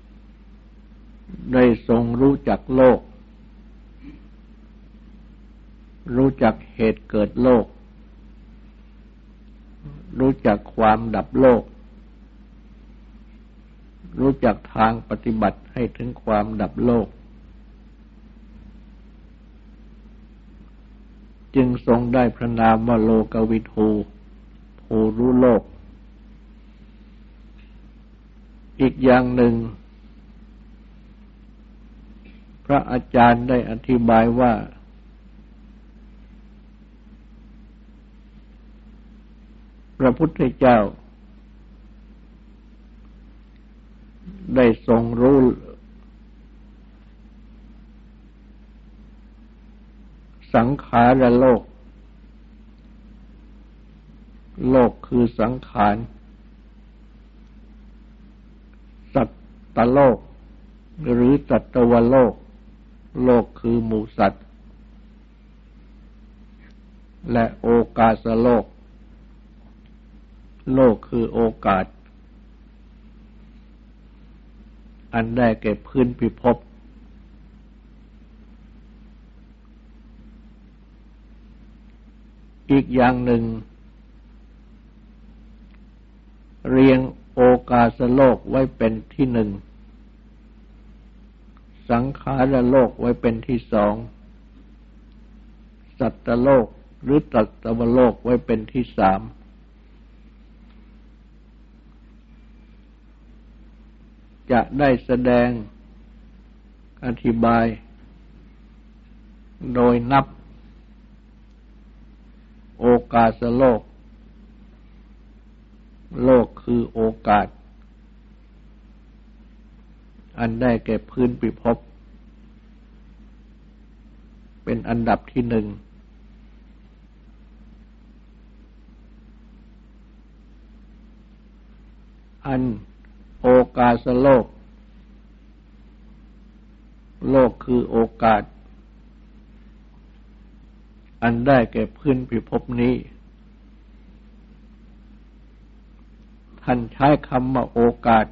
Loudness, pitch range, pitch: -19 LUFS, 115-145 Hz, 125 Hz